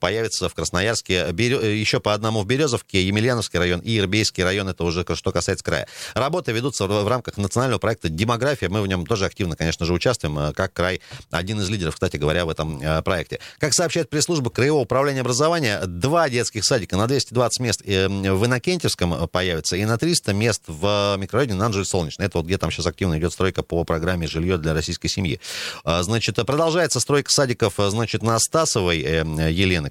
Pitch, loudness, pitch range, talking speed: 100 Hz, -21 LUFS, 90-120 Hz, 175 wpm